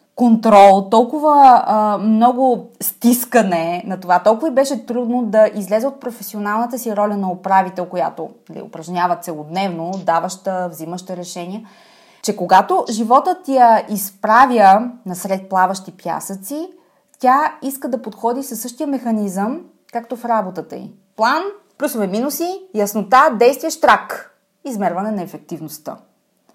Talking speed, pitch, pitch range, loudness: 125 wpm, 215 Hz, 190-255 Hz, -16 LUFS